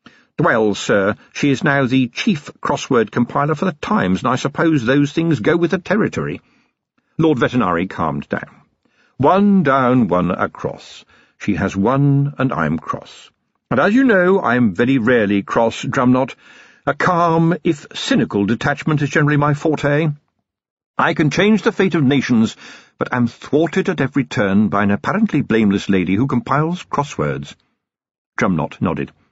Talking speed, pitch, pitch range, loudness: 155 wpm, 140 Hz, 115-165 Hz, -17 LUFS